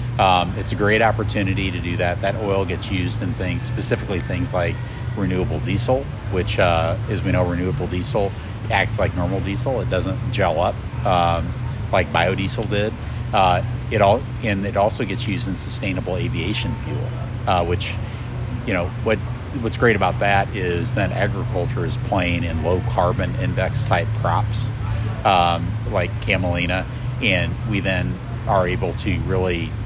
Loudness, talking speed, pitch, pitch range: -21 LUFS, 160 wpm, 110 Hz, 95-120 Hz